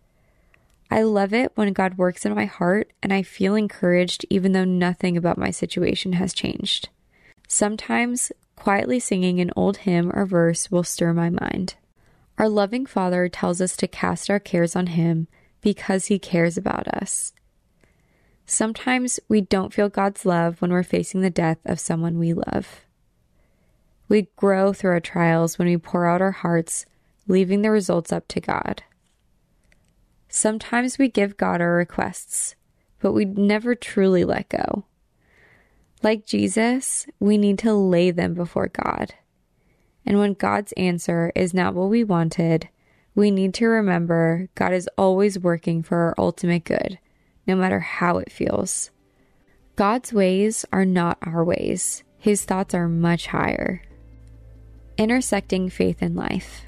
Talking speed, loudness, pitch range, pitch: 150 wpm, -22 LUFS, 175-210 Hz, 190 Hz